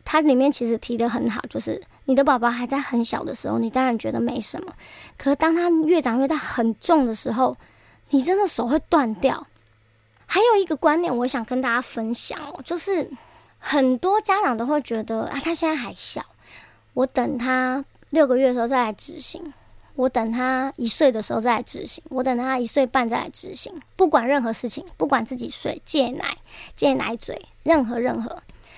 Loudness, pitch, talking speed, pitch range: -22 LUFS, 265 Hz, 280 characters per minute, 240-310 Hz